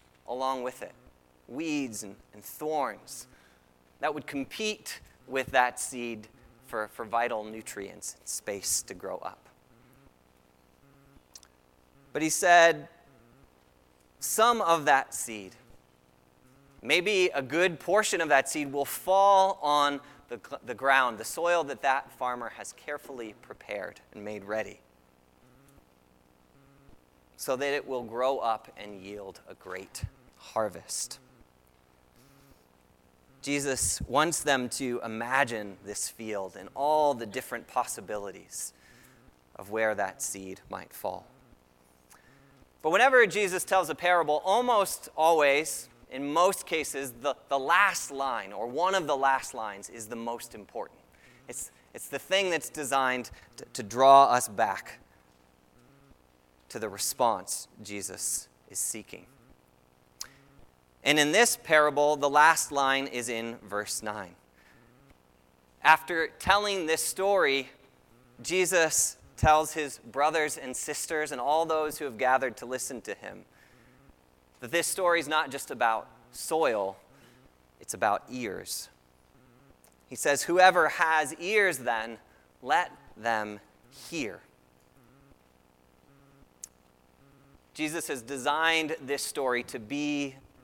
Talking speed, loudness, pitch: 120 wpm, -28 LUFS, 120 Hz